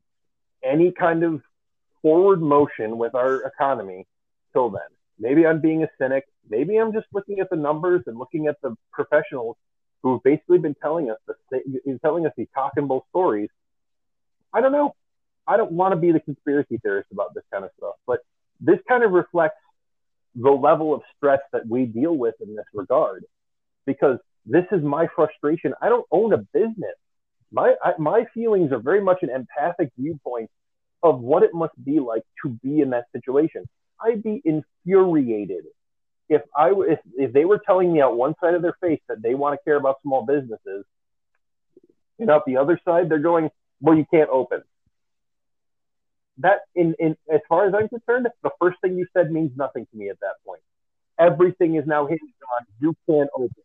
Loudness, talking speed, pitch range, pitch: -21 LUFS, 185 wpm, 145-200 Hz, 160 Hz